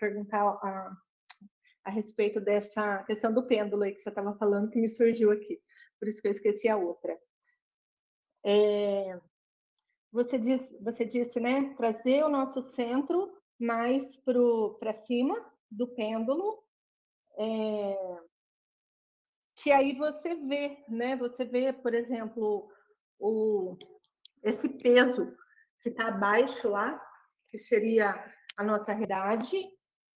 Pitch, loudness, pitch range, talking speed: 230 Hz, -30 LUFS, 210-265 Hz, 120 wpm